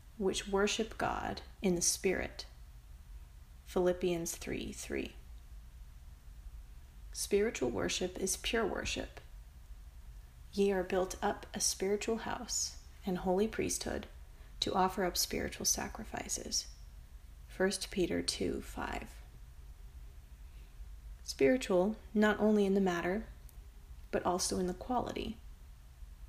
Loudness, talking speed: -35 LUFS, 100 wpm